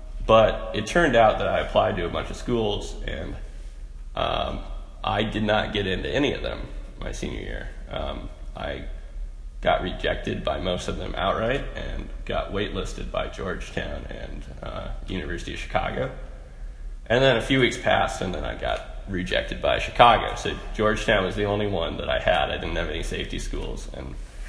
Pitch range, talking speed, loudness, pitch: 70-105 Hz, 180 wpm, -25 LUFS, 85 Hz